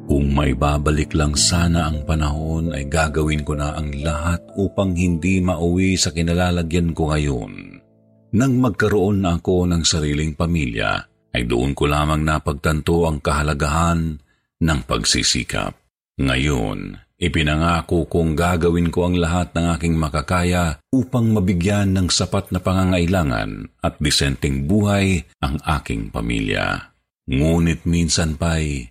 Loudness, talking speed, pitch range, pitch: -19 LUFS, 125 wpm, 75-90 Hz, 85 Hz